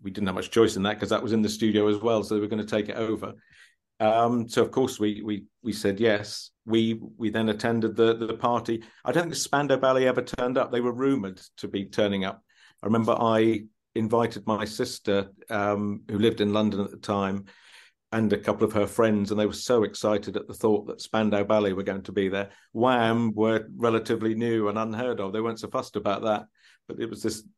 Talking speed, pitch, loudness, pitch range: 235 wpm, 110 Hz, -26 LUFS, 105-115 Hz